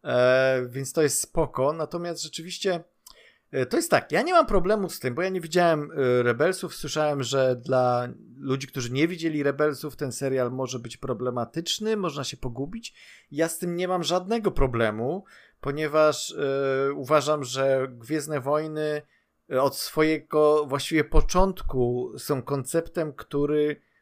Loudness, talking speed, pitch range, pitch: -26 LUFS, 140 wpm, 135-165 Hz, 150 Hz